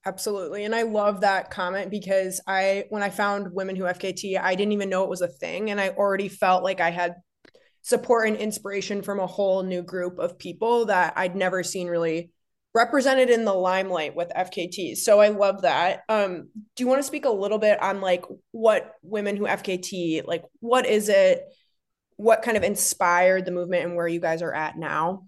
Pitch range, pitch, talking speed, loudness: 180-210 Hz, 195 Hz, 205 wpm, -24 LUFS